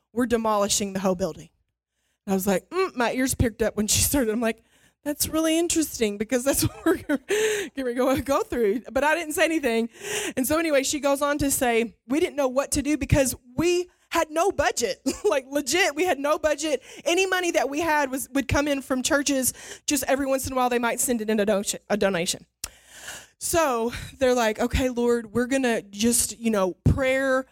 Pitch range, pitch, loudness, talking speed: 235-310 Hz, 270 Hz, -24 LUFS, 205 wpm